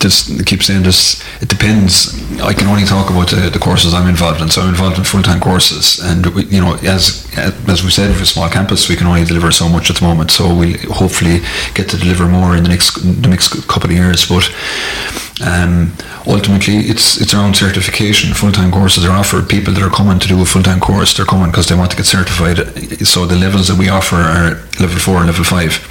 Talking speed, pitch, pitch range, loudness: 245 wpm, 90 Hz, 85-95 Hz, -10 LUFS